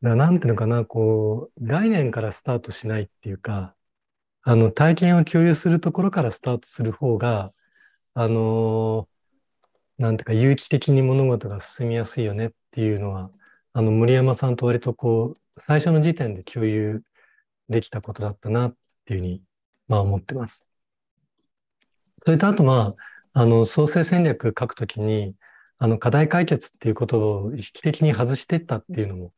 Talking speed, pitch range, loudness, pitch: 335 characters per minute, 110-145 Hz, -22 LUFS, 115 Hz